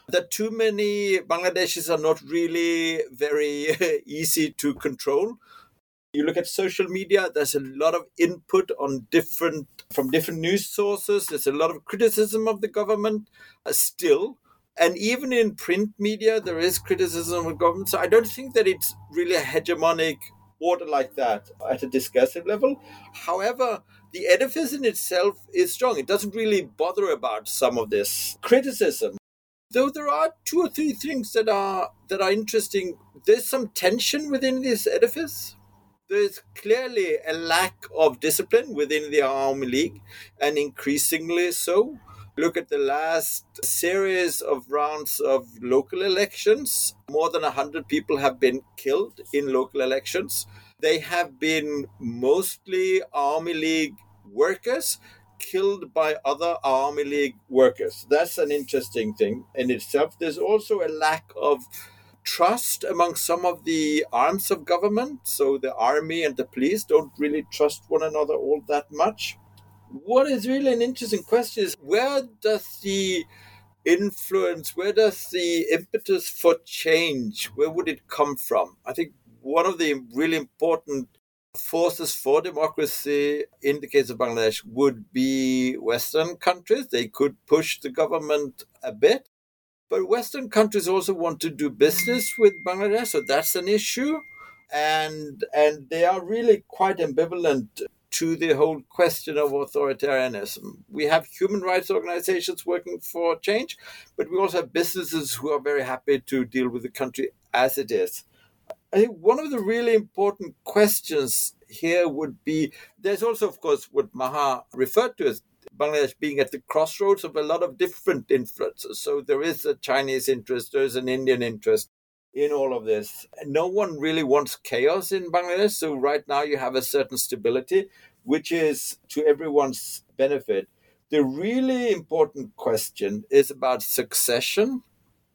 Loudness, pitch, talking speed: -24 LUFS, 185 Hz, 155 wpm